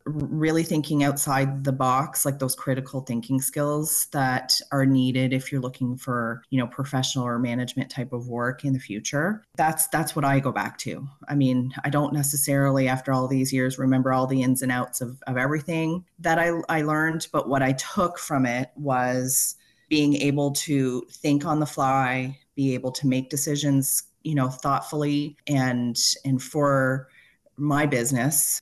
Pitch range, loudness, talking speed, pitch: 130-145 Hz, -24 LUFS, 175 wpm, 135 Hz